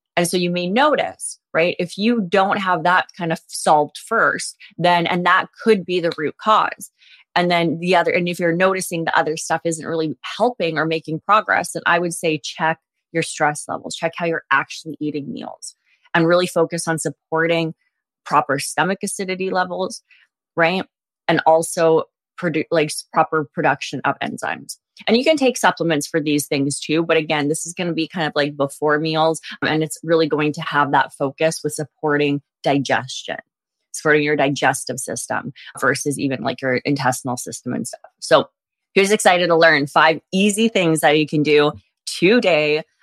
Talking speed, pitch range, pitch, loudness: 180 wpm, 150-180 Hz, 165 Hz, -19 LUFS